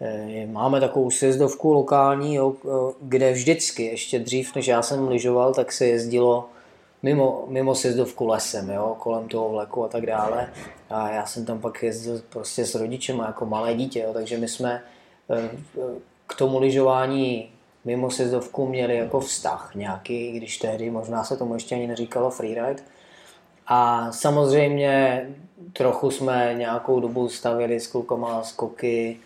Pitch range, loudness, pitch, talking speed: 115-135 Hz, -24 LUFS, 125 Hz, 150 wpm